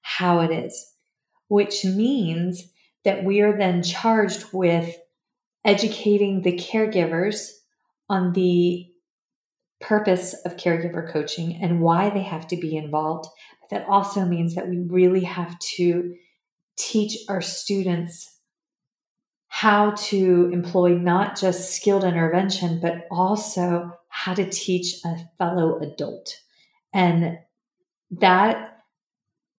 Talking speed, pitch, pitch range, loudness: 115 wpm, 180 Hz, 175-205 Hz, -22 LUFS